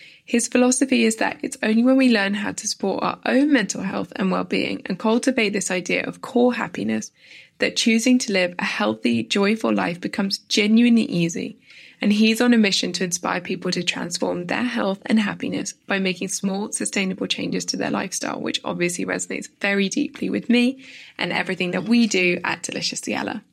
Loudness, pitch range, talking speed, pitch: -21 LUFS, 190-240 Hz, 185 wpm, 215 Hz